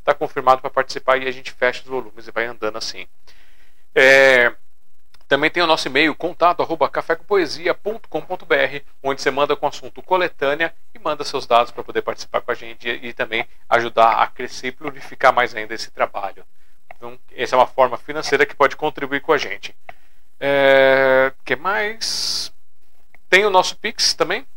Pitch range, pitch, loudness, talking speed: 120-155 Hz, 135 Hz, -18 LUFS, 170 wpm